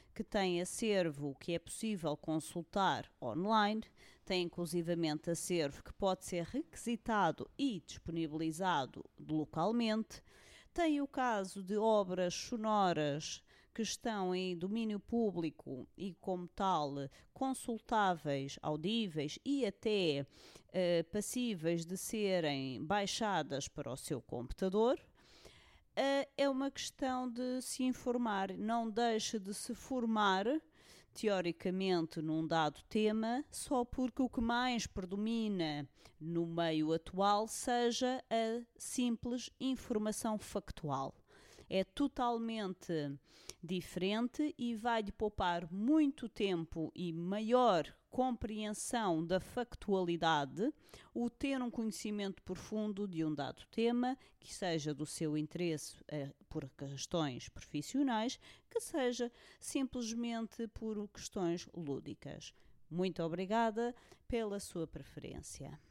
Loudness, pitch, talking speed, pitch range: -38 LUFS, 200 Hz, 105 wpm, 165-235 Hz